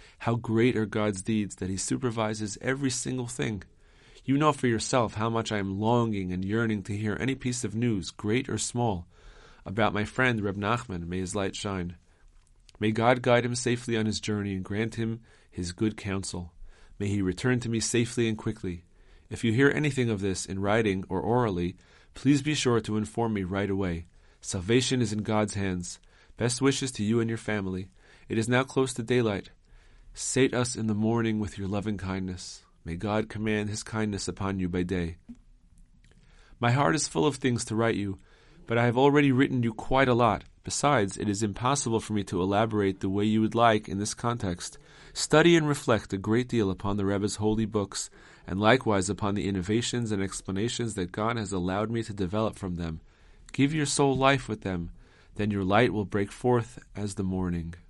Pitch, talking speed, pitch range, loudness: 110 Hz, 200 wpm, 95-120 Hz, -28 LUFS